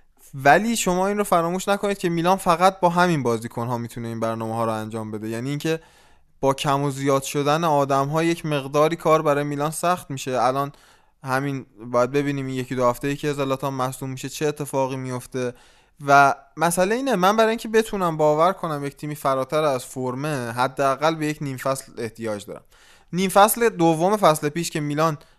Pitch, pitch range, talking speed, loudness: 145 Hz, 130-170 Hz, 190 wpm, -22 LUFS